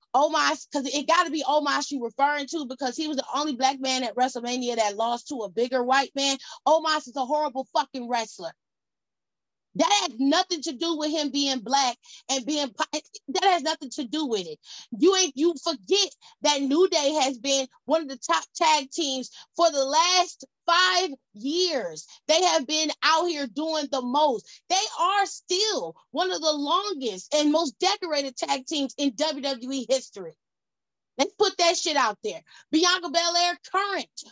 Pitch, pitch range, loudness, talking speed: 300 Hz, 270-335 Hz, -25 LUFS, 180 wpm